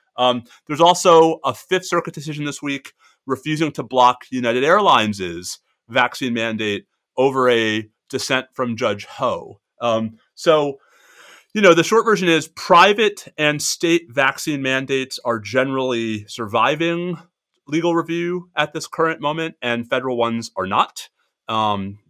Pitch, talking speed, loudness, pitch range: 135 Hz, 135 wpm, -19 LUFS, 120-165 Hz